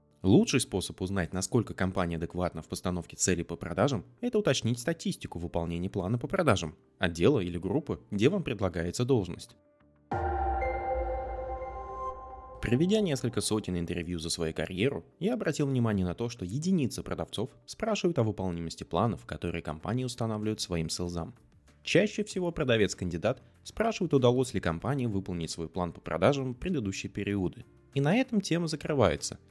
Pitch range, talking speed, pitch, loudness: 90-145 Hz, 140 wpm, 105 Hz, -31 LUFS